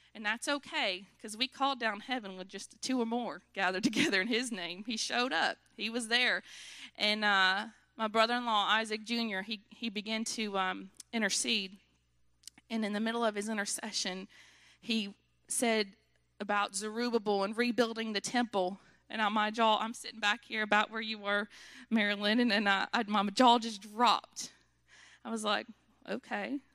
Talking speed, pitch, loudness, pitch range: 170 wpm, 220 Hz, -32 LUFS, 205-235 Hz